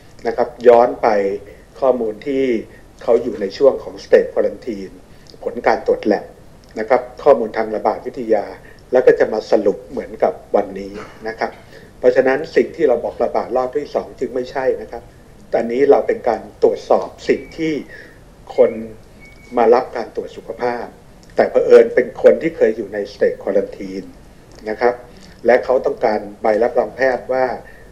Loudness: -17 LUFS